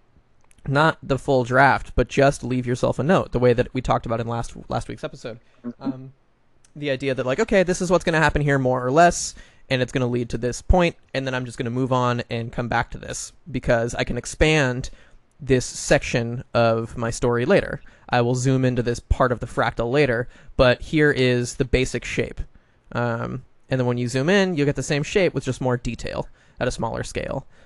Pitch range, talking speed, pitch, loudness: 120-140 Hz, 225 wpm, 125 Hz, -22 LUFS